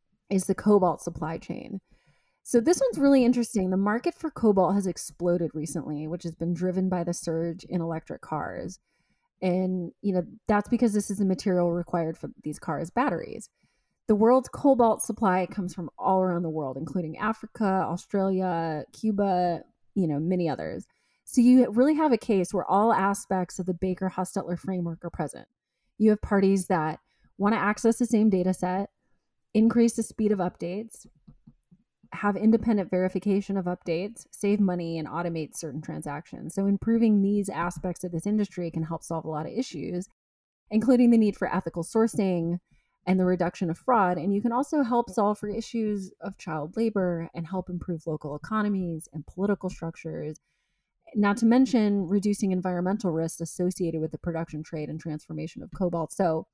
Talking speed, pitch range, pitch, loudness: 170 wpm, 170-210 Hz, 185 Hz, -27 LUFS